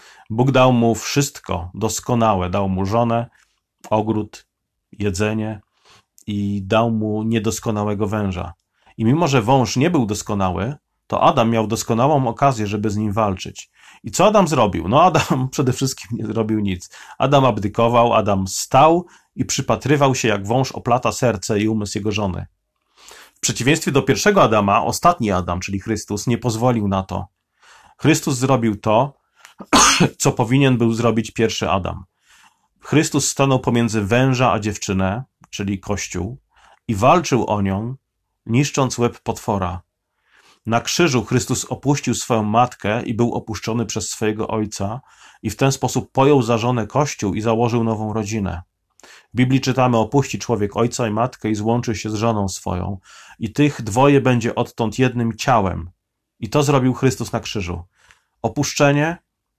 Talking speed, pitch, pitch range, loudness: 145 wpm, 115 Hz, 105-130 Hz, -19 LUFS